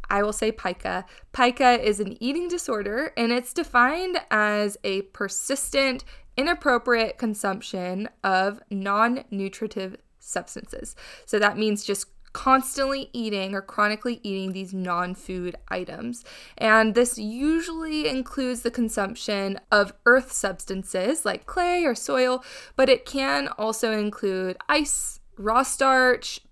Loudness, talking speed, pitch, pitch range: -24 LUFS, 120 wpm, 225 Hz, 200-255 Hz